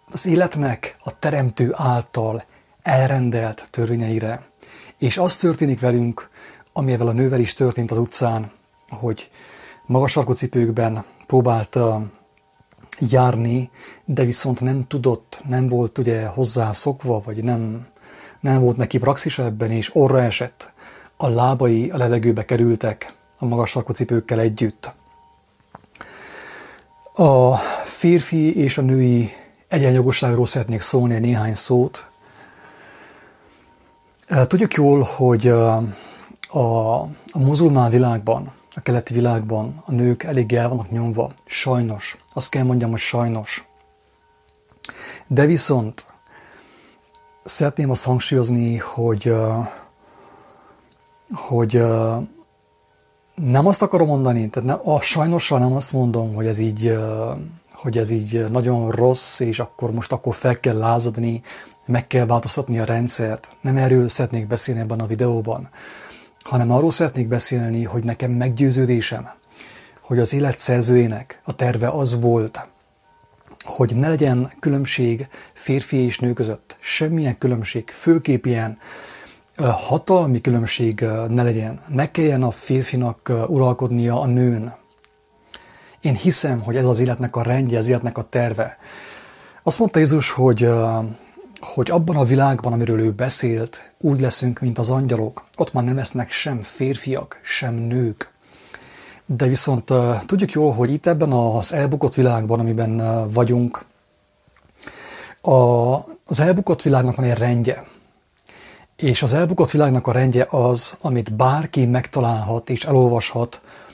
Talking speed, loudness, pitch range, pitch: 125 wpm, -19 LUFS, 115-135 Hz, 125 Hz